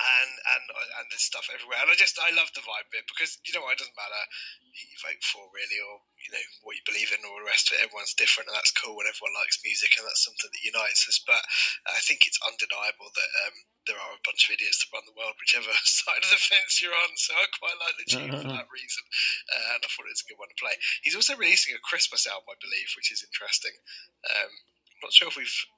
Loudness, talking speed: -25 LUFS, 265 wpm